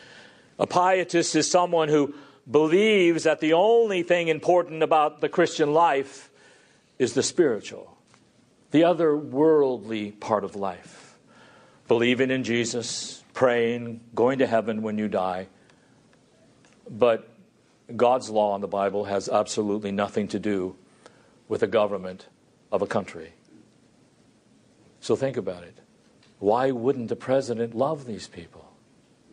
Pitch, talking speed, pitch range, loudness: 130 Hz, 125 wpm, 105-155 Hz, -24 LUFS